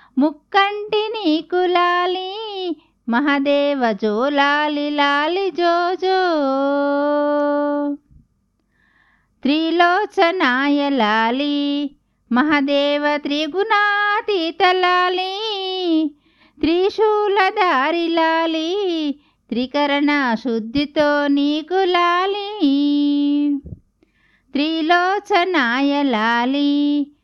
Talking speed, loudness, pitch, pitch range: 35 wpm, -18 LUFS, 300 Hz, 285-360 Hz